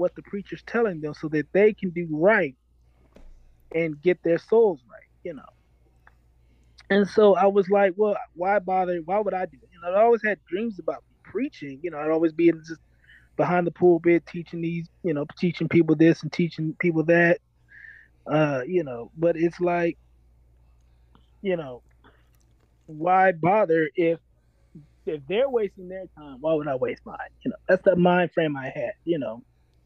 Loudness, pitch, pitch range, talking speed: -24 LUFS, 170 Hz, 140-185 Hz, 185 wpm